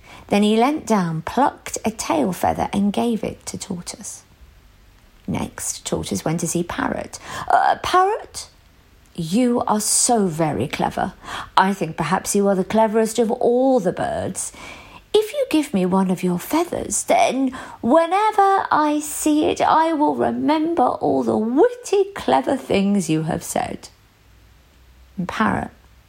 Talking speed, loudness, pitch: 145 wpm, -20 LUFS, 220 Hz